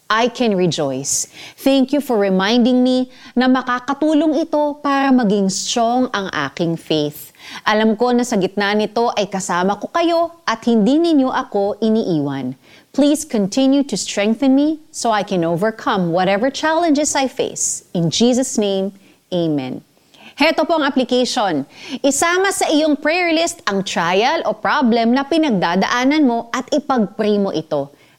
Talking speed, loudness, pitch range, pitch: 145 wpm, -17 LUFS, 195-280 Hz, 235 Hz